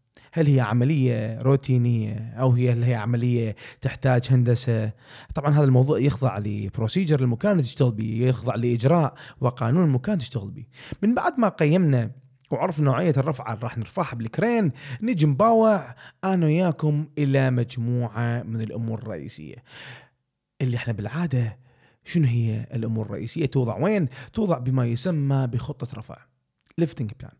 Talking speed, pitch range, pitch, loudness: 130 wpm, 120-150 Hz, 130 Hz, -23 LUFS